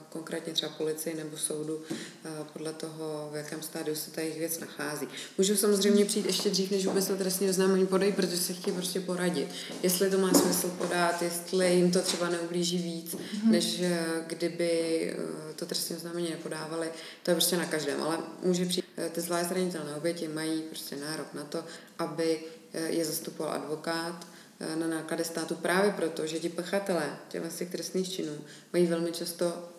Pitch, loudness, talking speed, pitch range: 170 Hz, -30 LUFS, 165 wpm, 160-180 Hz